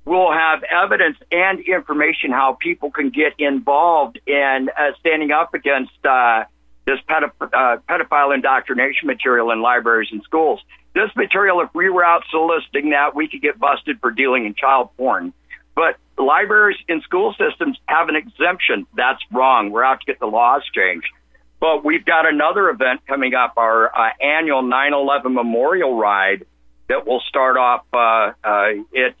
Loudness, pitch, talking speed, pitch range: -17 LUFS, 145 Hz, 165 wpm, 125-170 Hz